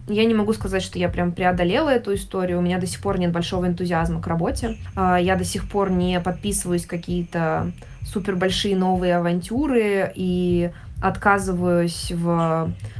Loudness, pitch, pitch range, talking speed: -22 LUFS, 180 Hz, 175-190 Hz, 155 wpm